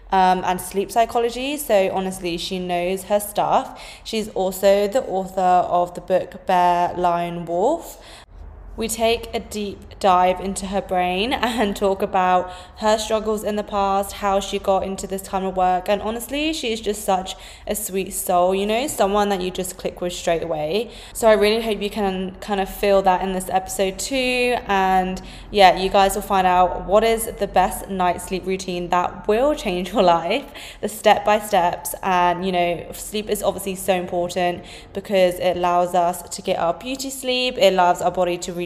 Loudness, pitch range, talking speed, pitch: -20 LUFS, 180-210 Hz, 190 wpm, 190 Hz